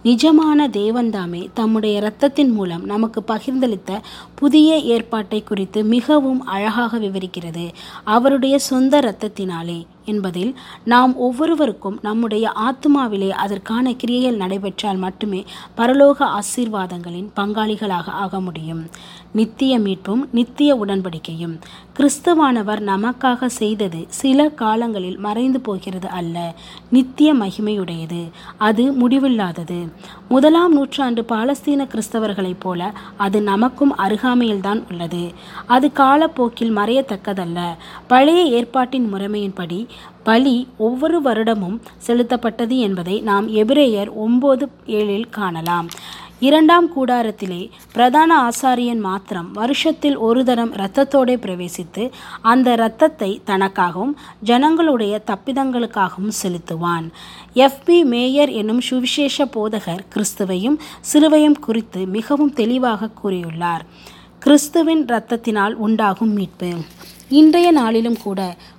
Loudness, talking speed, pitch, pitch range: -17 LUFS, 90 wpm, 220 Hz, 195-260 Hz